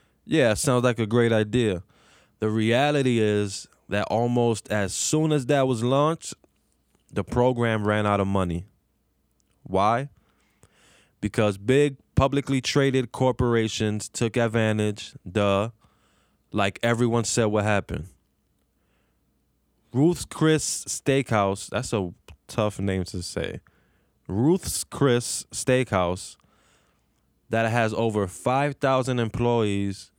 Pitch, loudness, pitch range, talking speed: 110 Hz, -24 LUFS, 100-125 Hz, 105 wpm